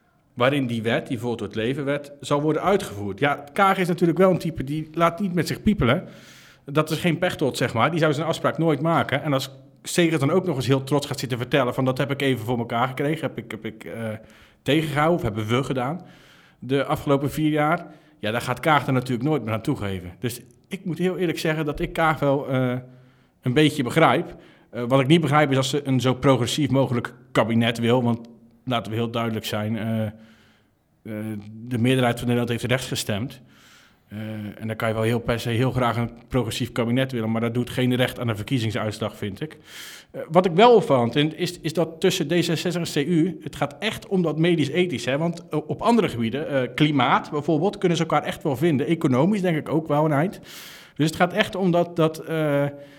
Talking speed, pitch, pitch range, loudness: 225 wpm, 140 Hz, 120-160 Hz, -23 LUFS